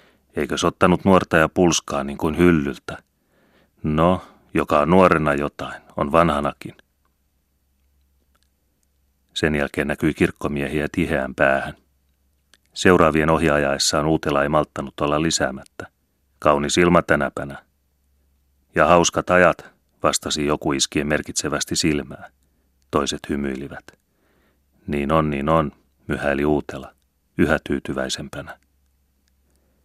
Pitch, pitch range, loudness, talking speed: 70 Hz, 70-80 Hz, -20 LUFS, 100 wpm